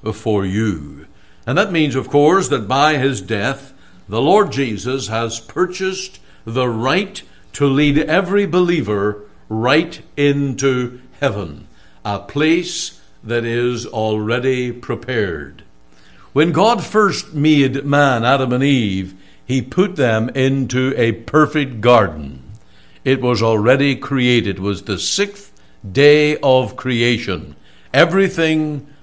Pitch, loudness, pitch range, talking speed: 130 Hz, -16 LUFS, 110-145 Hz, 120 wpm